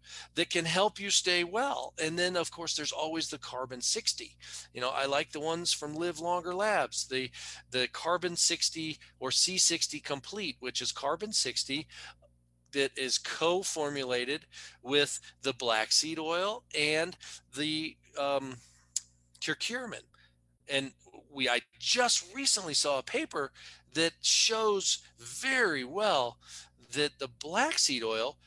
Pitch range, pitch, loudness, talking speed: 130-175 Hz, 150 Hz, -30 LUFS, 135 wpm